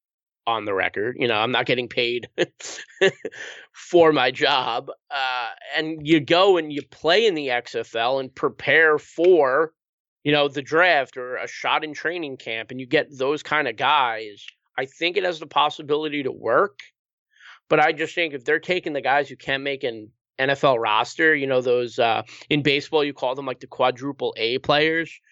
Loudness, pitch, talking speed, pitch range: -22 LUFS, 150 Hz, 185 wpm, 135-165 Hz